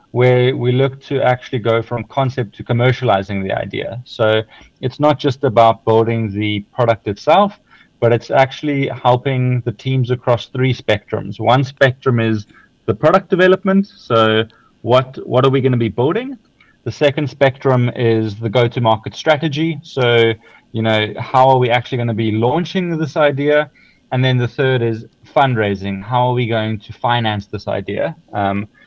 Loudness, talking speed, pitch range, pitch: -16 LUFS, 165 wpm, 110-135 Hz, 125 Hz